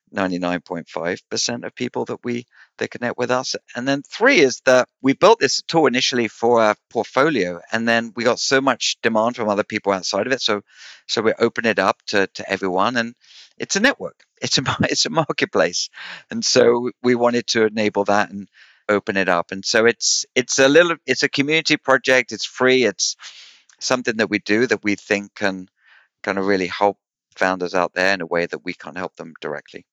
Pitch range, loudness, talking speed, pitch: 95-125 Hz, -19 LUFS, 210 wpm, 110 Hz